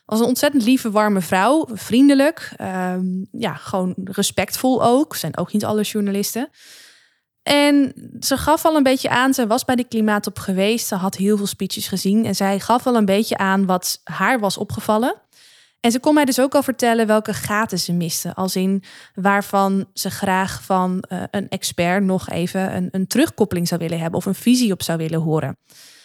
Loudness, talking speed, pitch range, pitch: -19 LUFS, 190 wpm, 190-240 Hz, 200 Hz